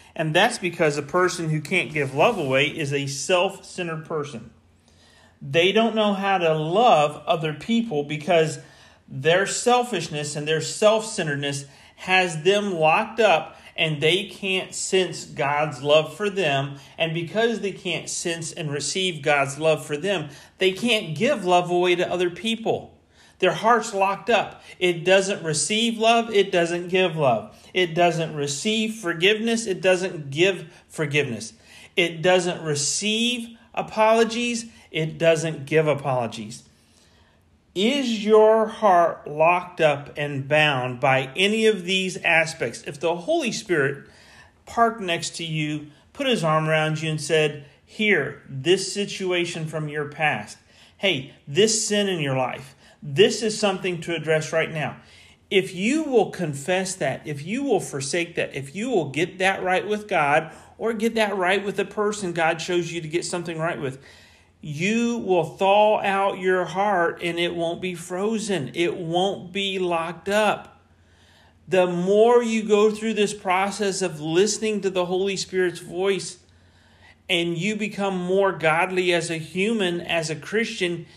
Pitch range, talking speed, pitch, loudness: 155-200 Hz, 155 wpm, 175 Hz, -22 LUFS